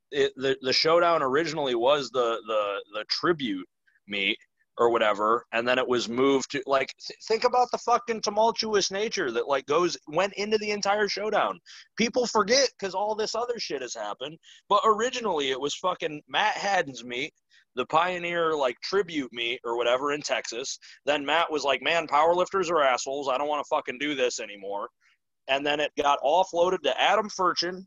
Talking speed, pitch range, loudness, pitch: 185 wpm, 135-215 Hz, -26 LUFS, 170 Hz